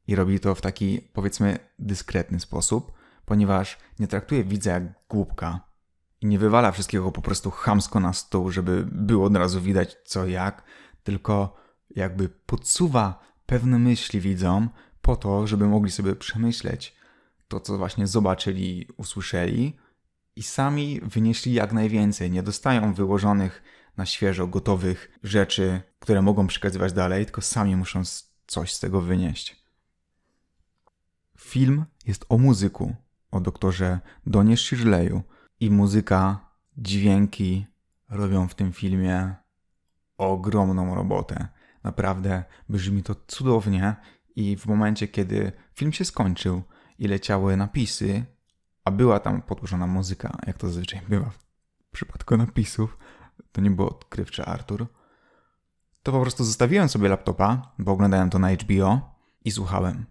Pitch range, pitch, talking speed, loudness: 95-110 Hz, 100 Hz, 130 wpm, -24 LUFS